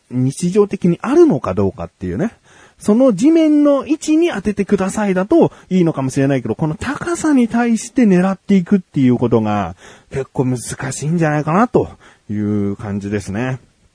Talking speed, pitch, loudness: 360 characters per minute, 170 Hz, -16 LUFS